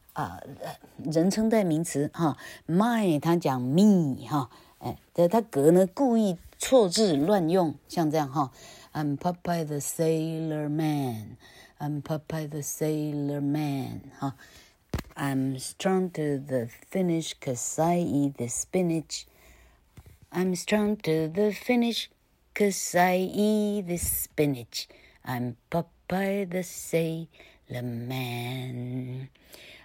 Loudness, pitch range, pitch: -27 LUFS, 135-185 Hz, 155 Hz